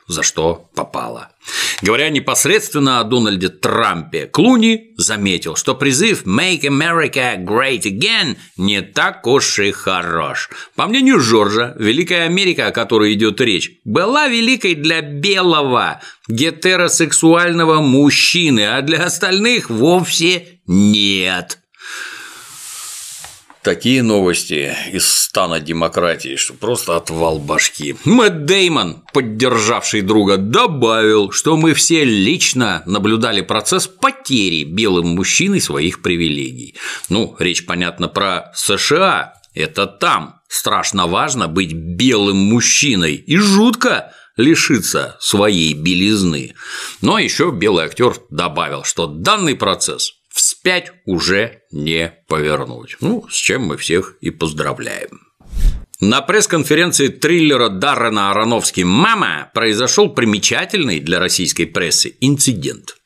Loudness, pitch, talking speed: -14 LUFS, 125 Hz, 110 wpm